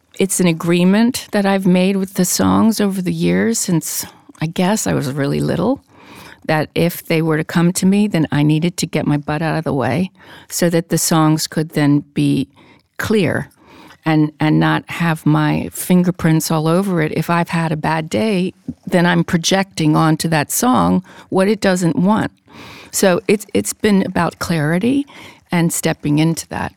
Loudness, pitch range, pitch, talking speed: -16 LUFS, 155-190 Hz, 170 Hz, 180 wpm